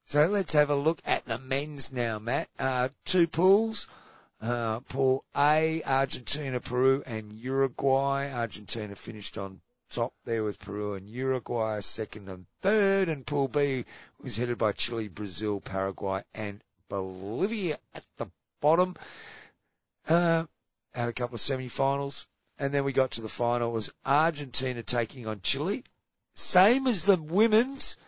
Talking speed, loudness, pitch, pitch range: 145 wpm, -28 LUFS, 130 Hz, 110-145 Hz